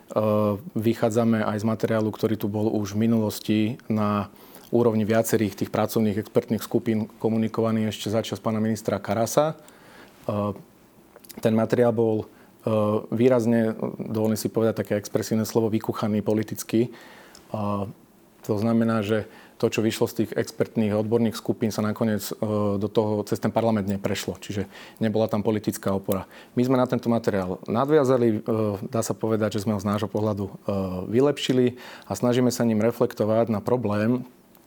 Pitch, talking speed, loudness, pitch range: 110 Hz, 140 wpm, -25 LUFS, 105-115 Hz